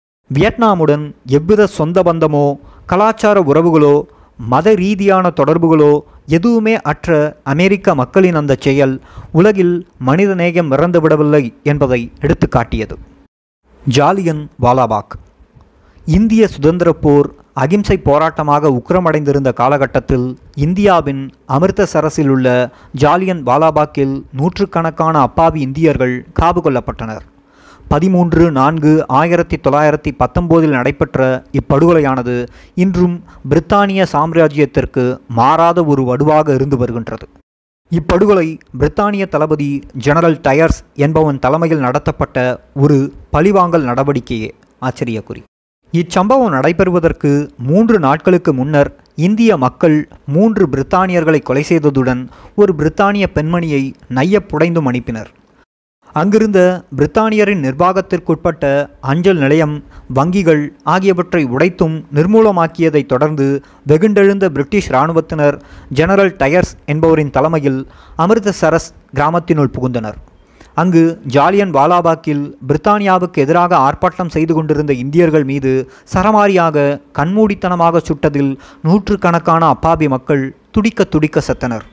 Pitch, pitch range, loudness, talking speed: 155 Hz, 135-175 Hz, -13 LUFS, 90 wpm